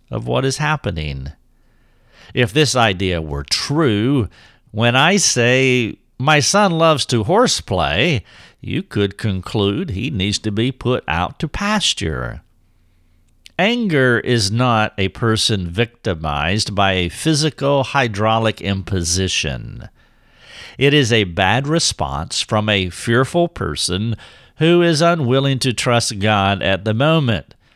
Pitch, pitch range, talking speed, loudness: 110 Hz, 95-135 Hz, 125 wpm, -17 LUFS